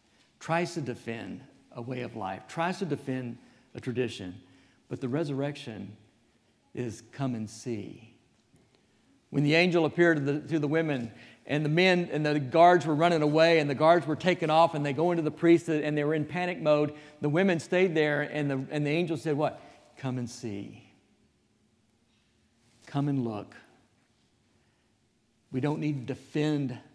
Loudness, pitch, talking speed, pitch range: -28 LUFS, 145 Hz, 170 wpm, 120-160 Hz